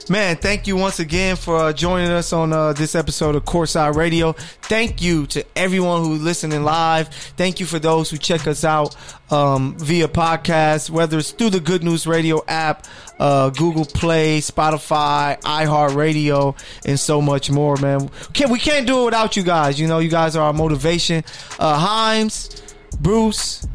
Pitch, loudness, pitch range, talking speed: 160 Hz, -18 LUFS, 150-175 Hz, 175 wpm